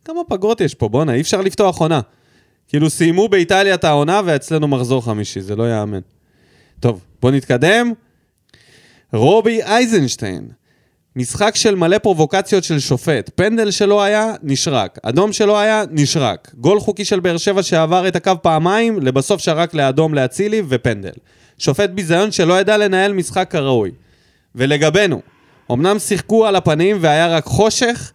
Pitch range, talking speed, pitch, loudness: 135-205 Hz, 145 wpm, 170 Hz, -15 LUFS